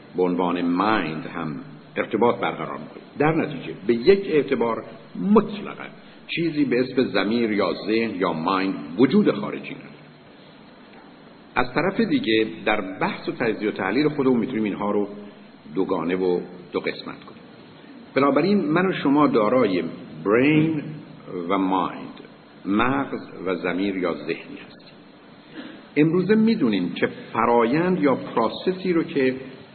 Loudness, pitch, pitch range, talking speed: -22 LUFS, 130 Hz, 100-160 Hz, 135 wpm